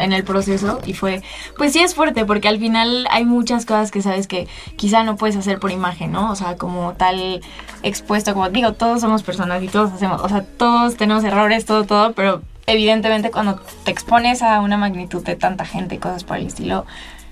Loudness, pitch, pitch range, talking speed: -18 LUFS, 210 Hz, 190-225 Hz, 210 wpm